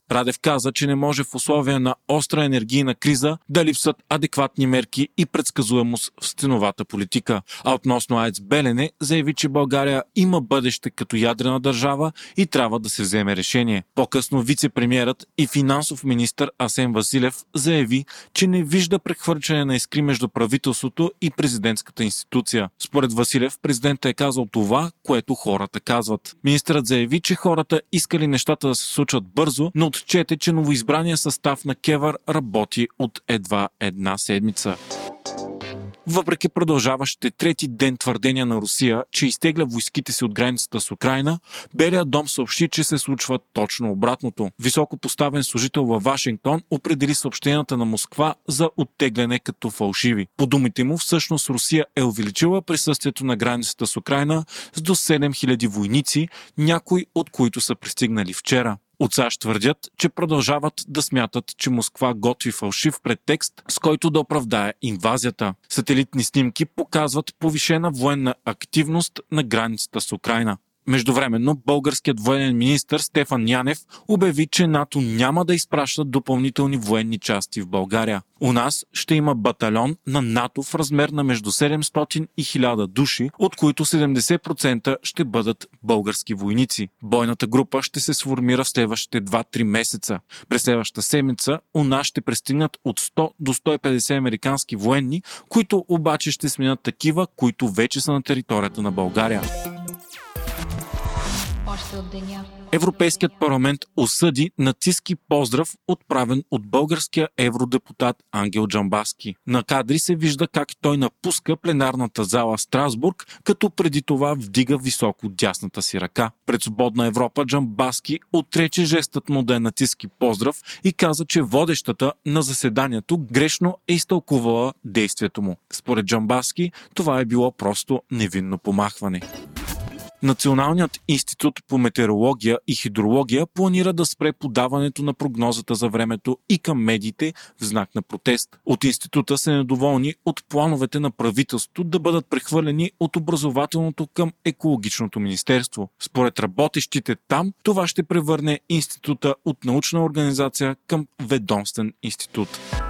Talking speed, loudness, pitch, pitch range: 140 wpm, -21 LUFS, 135 Hz, 120-155 Hz